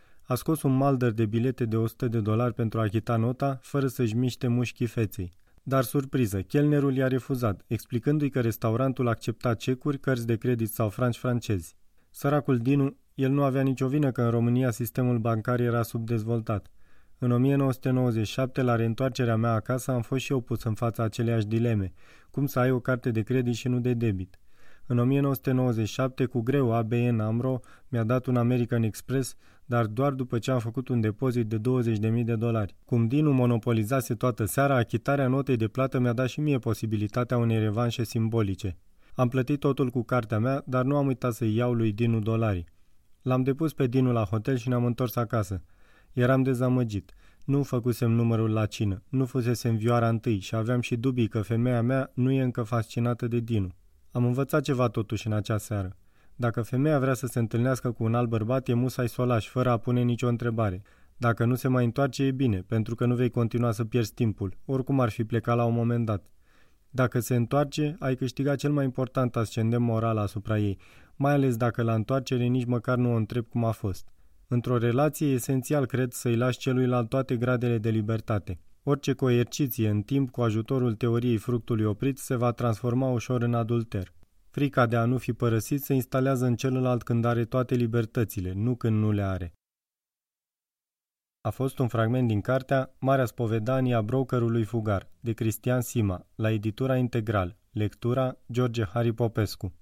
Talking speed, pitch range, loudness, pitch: 185 wpm, 115-130 Hz, -27 LUFS, 120 Hz